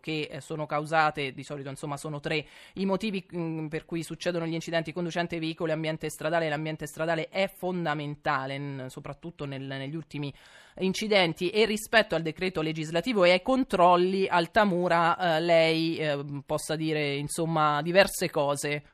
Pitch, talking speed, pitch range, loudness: 160 Hz, 150 wpm, 150-175 Hz, -28 LUFS